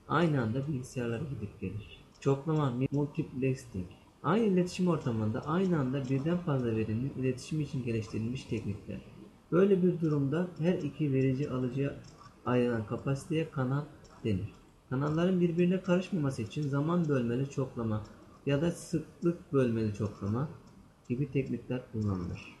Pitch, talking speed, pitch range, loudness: 135 Hz, 120 wpm, 115-155 Hz, -32 LUFS